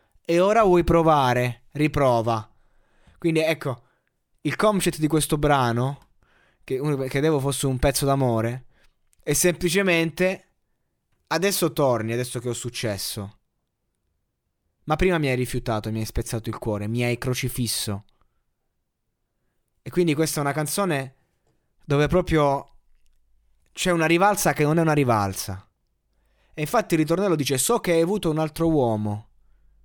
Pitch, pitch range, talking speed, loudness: 135 Hz, 115-160 Hz, 135 wpm, -23 LUFS